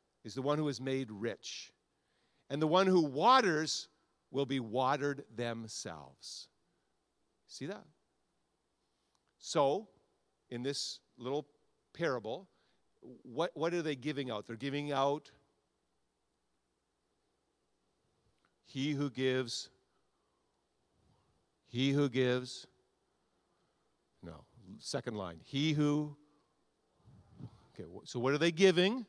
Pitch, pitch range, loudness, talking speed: 140 Hz, 130-150 Hz, -34 LUFS, 100 wpm